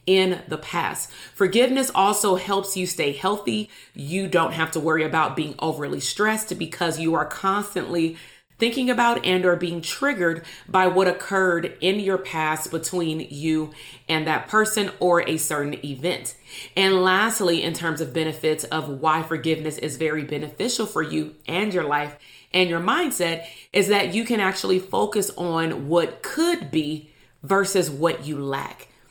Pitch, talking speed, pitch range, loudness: 170 Hz, 160 wpm, 155-195 Hz, -23 LUFS